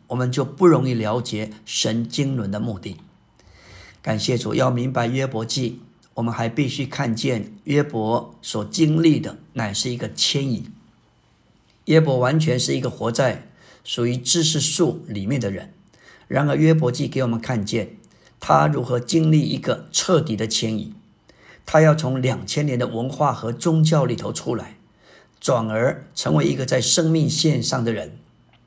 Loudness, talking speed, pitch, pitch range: -21 LUFS, 230 characters per minute, 125 Hz, 115-150 Hz